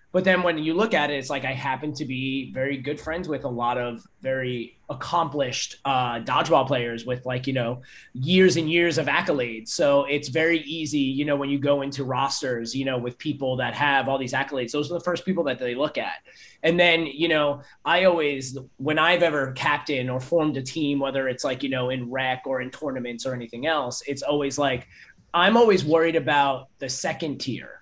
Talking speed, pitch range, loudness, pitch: 215 wpm, 130-155 Hz, -24 LUFS, 140 Hz